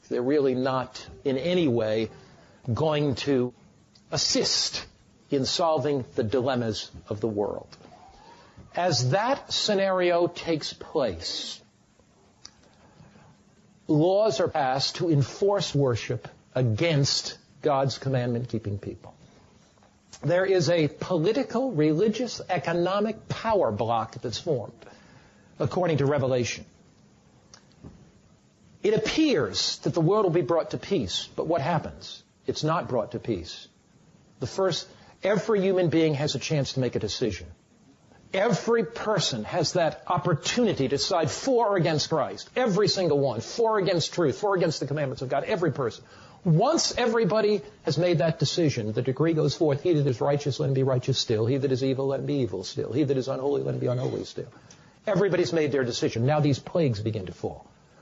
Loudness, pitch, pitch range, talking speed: -26 LUFS, 150 Hz, 130-180 Hz, 155 wpm